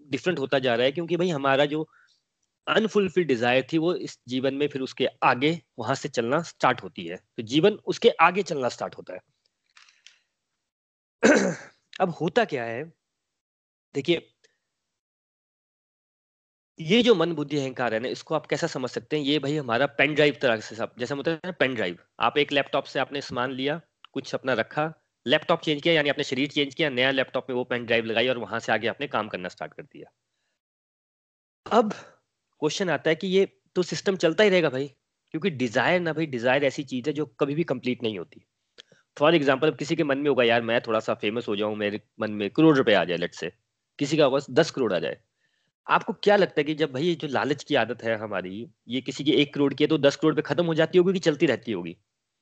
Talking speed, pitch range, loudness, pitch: 210 wpm, 130-165 Hz, -25 LUFS, 145 Hz